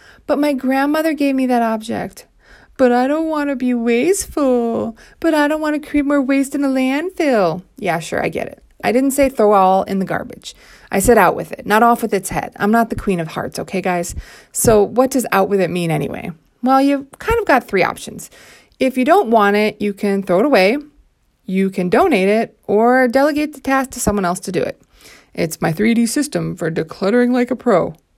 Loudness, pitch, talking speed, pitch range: -16 LUFS, 235 Hz, 220 wpm, 195-275 Hz